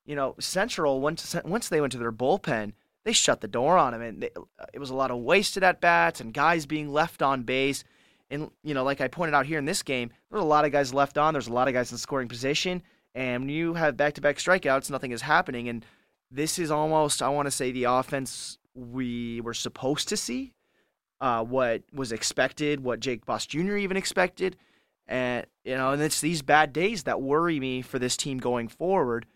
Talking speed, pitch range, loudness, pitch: 220 wpm, 125-160 Hz, -26 LUFS, 140 Hz